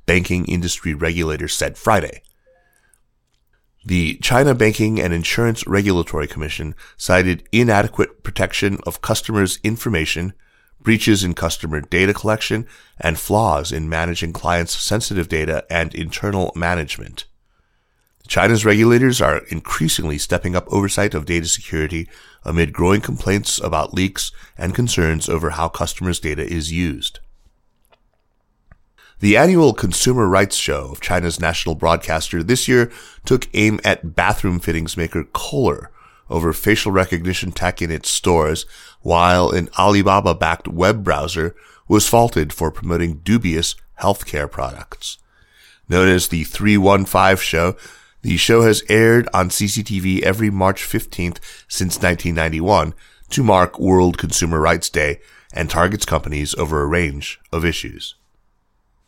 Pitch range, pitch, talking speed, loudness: 80-105 Hz, 90 Hz, 125 wpm, -18 LUFS